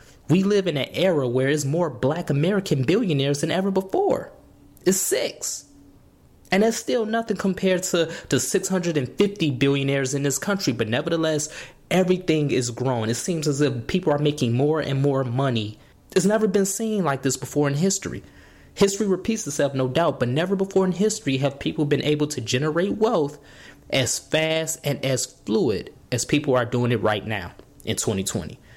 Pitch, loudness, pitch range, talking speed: 150 Hz, -23 LUFS, 135-190 Hz, 175 wpm